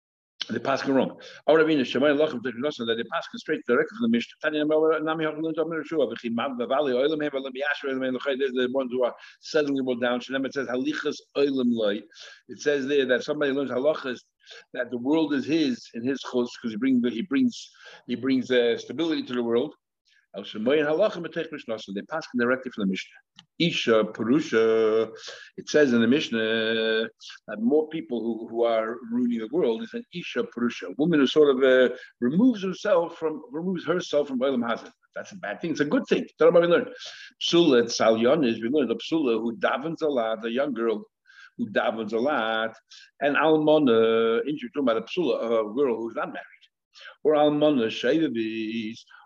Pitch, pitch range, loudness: 135 Hz, 115-155 Hz, -25 LUFS